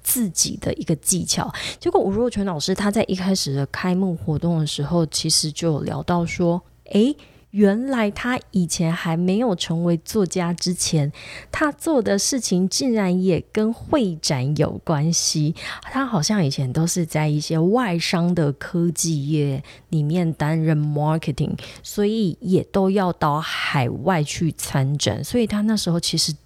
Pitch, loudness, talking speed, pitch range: 170 Hz, -21 LUFS, 250 characters per minute, 155-200 Hz